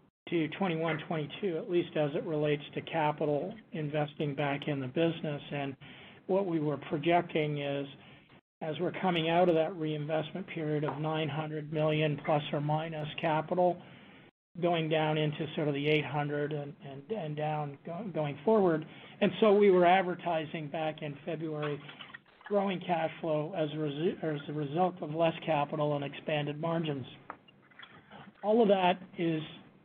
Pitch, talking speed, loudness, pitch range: 155 Hz, 155 wpm, -32 LUFS, 150-175 Hz